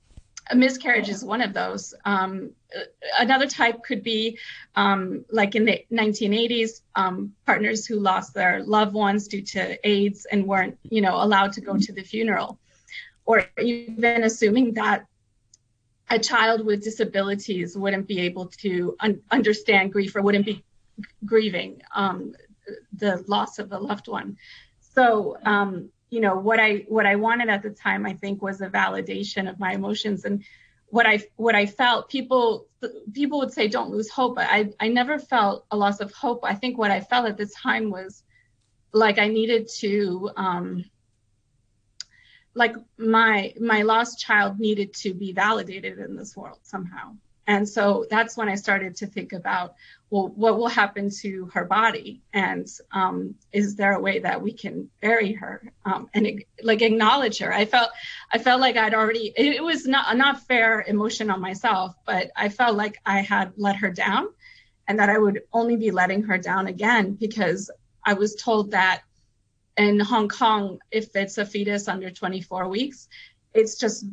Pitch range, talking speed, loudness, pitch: 195-225 Hz, 175 wpm, -23 LUFS, 210 Hz